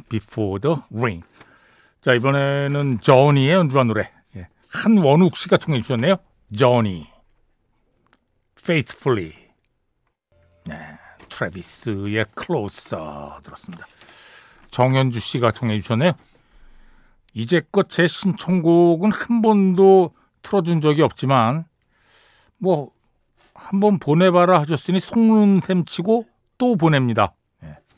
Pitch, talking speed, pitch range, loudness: 140 Hz, 245 characters per minute, 115-185 Hz, -18 LUFS